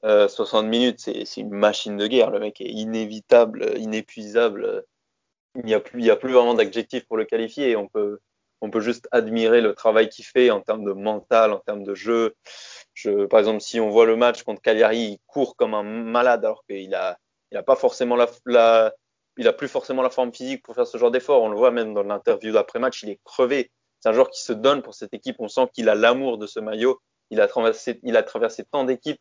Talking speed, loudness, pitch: 220 wpm, -21 LUFS, 120 Hz